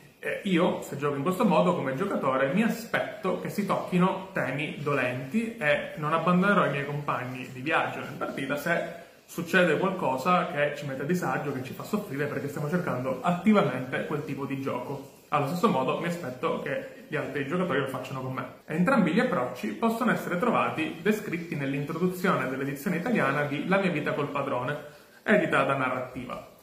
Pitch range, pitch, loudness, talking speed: 140-185 Hz, 150 Hz, -28 LUFS, 180 wpm